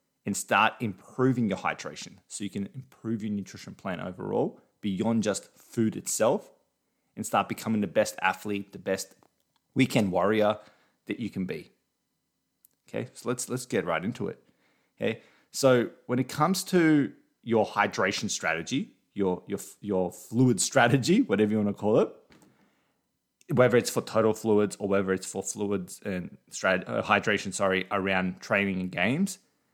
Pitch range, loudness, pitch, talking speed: 100-125 Hz, -28 LUFS, 105 Hz, 155 wpm